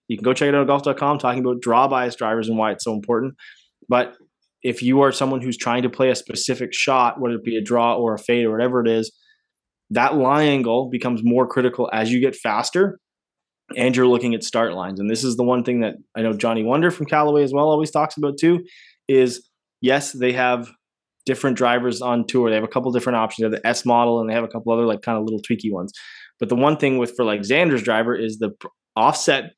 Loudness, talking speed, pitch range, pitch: -20 LUFS, 245 wpm, 115-135 Hz, 125 Hz